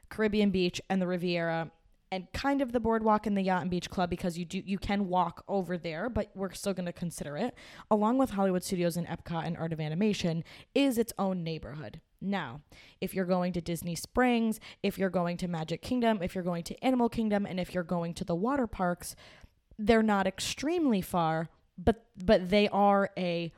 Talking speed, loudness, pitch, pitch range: 205 wpm, -31 LUFS, 190 Hz, 175-215 Hz